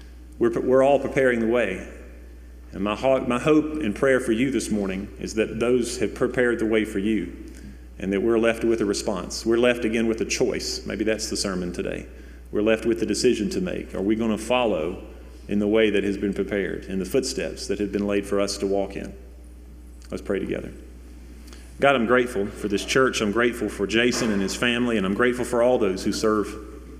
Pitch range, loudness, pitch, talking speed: 90-120 Hz, -23 LUFS, 105 Hz, 215 wpm